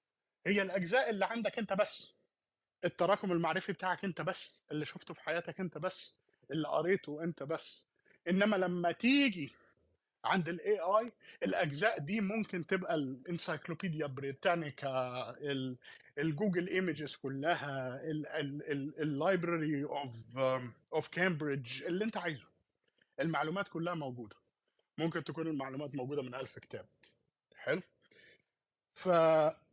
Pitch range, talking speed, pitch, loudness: 145-185 Hz, 110 wpm, 165 Hz, -36 LUFS